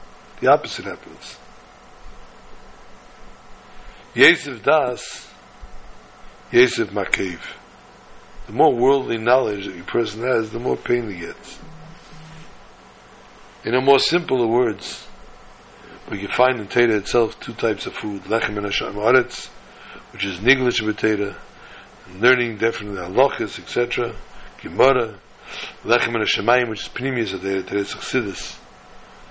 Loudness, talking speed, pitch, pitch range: -20 LUFS, 120 wpm, 115 Hz, 100-125 Hz